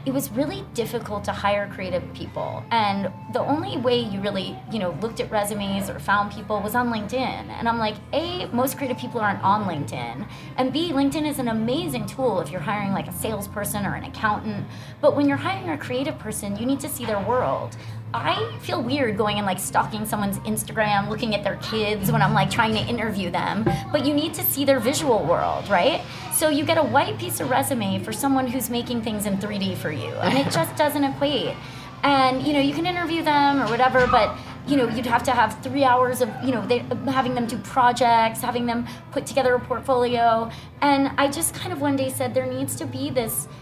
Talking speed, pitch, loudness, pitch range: 220 wpm, 245 Hz, -23 LUFS, 210-275 Hz